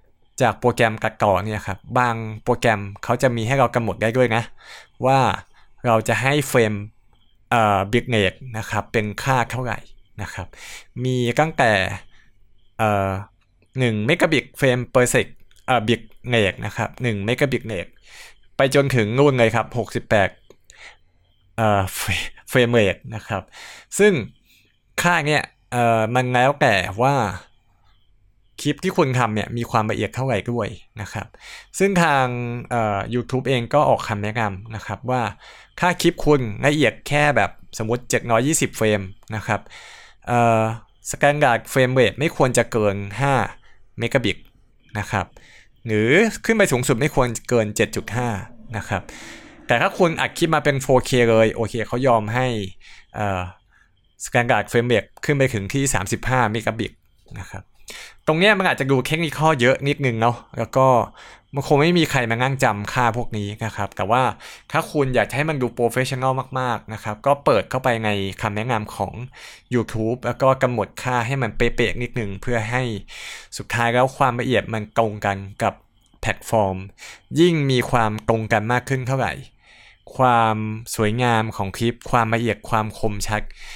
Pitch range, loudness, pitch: 105-130 Hz, -20 LUFS, 115 Hz